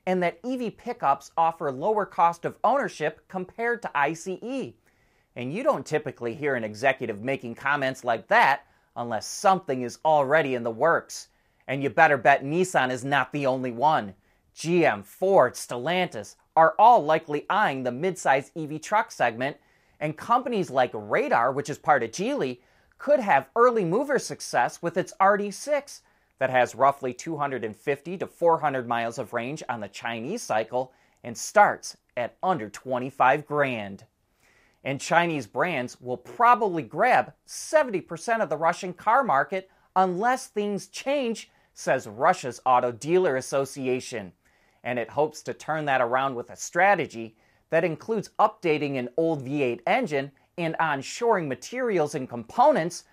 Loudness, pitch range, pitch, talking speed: -25 LUFS, 125-185 Hz, 150 Hz, 145 wpm